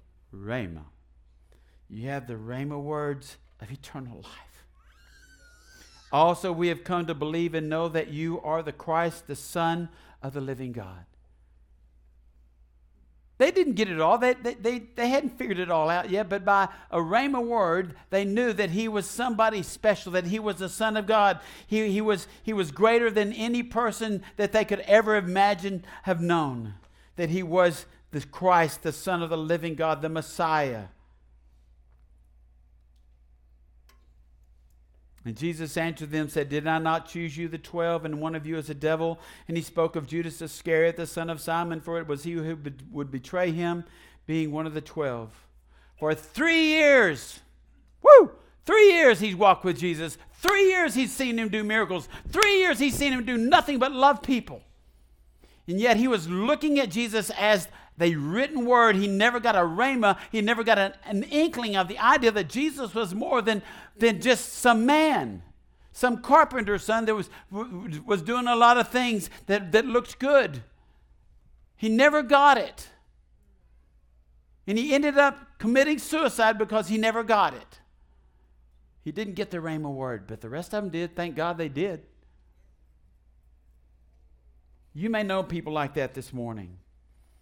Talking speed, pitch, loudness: 170 wpm, 170 Hz, -25 LUFS